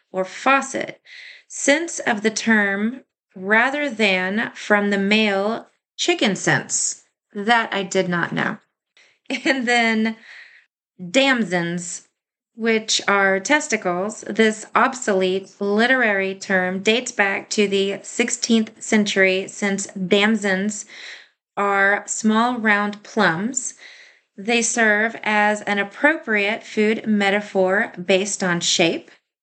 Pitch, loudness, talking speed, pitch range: 210 Hz, -19 LUFS, 100 wpm, 195-235 Hz